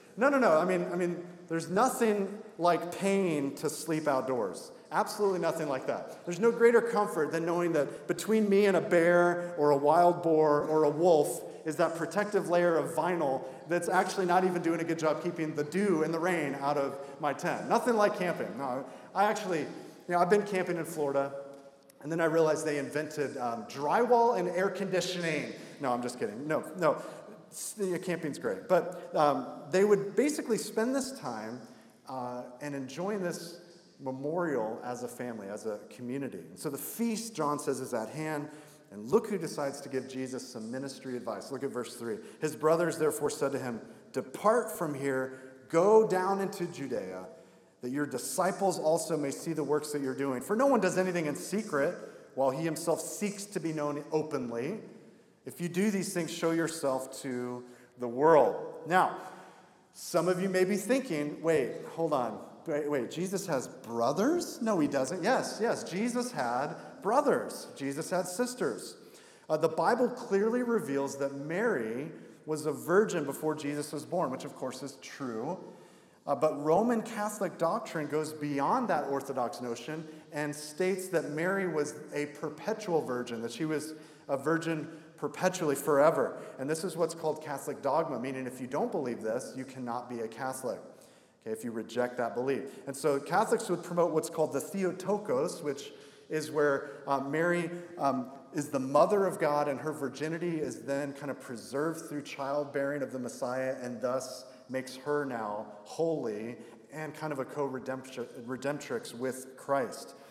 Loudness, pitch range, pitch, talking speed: -31 LUFS, 140-185 Hz, 155 Hz, 175 wpm